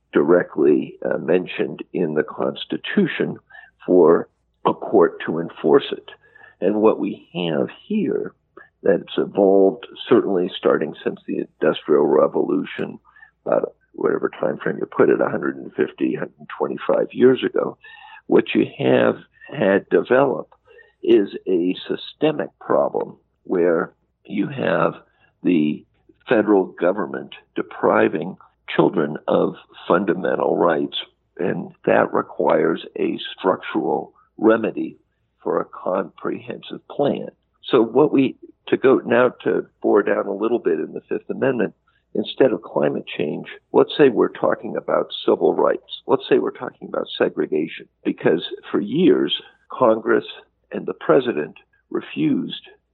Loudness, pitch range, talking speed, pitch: -20 LUFS, 360-430 Hz, 120 wpm, 400 Hz